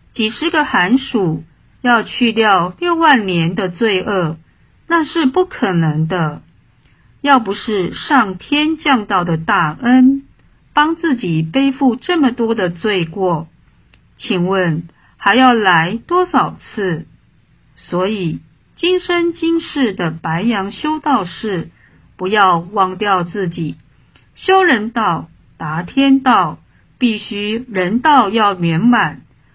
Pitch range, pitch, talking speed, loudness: 180-270 Hz, 215 Hz, 160 characters per minute, -15 LUFS